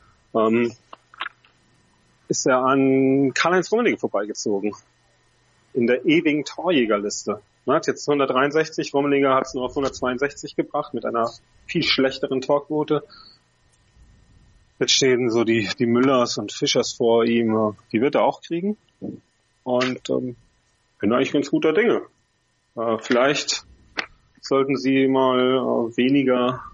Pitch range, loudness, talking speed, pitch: 115-140 Hz, -21 LUFS, 130 wpm, 130 Hz